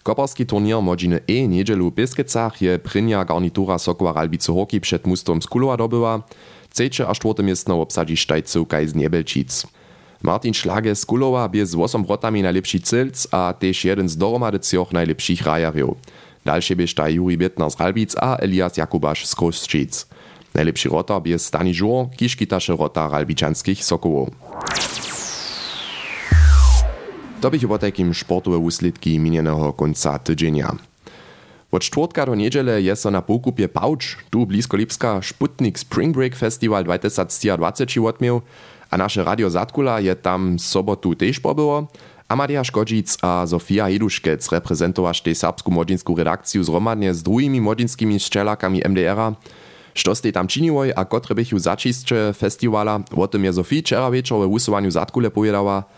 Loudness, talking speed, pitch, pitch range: -19 LUFS, 150 wpm, 95 Hz, 85-110 Hz